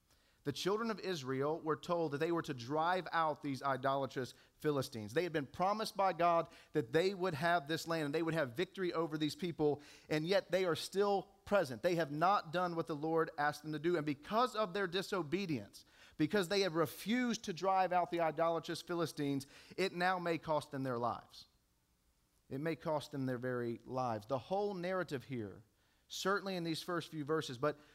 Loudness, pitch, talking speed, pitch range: -37 LUFS, 160 Hz, 200 wpm, 140-180 Hz